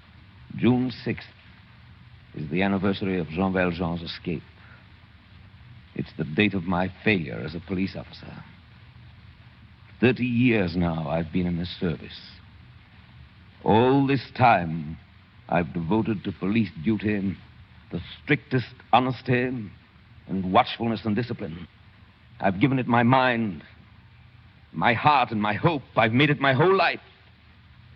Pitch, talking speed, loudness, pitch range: 105 Hz, 125 wpm, -24 LUFS, 95-115 Hz